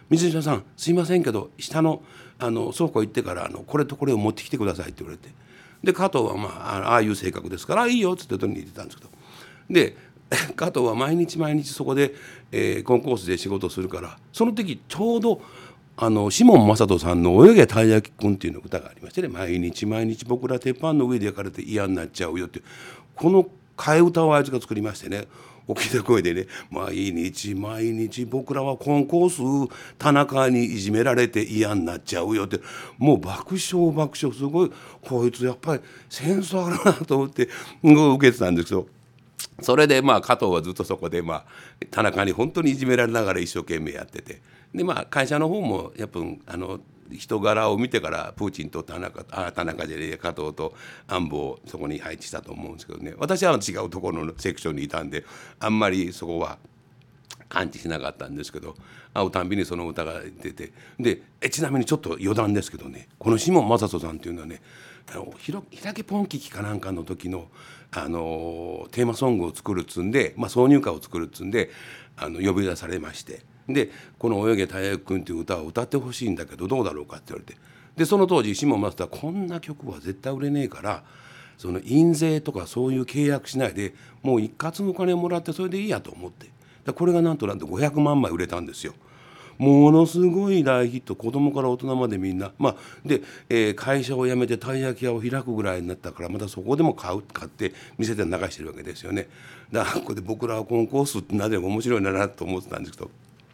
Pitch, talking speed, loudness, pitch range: 125 Hz, 405 characters per minute, -23 LUFS, 100-150 Hz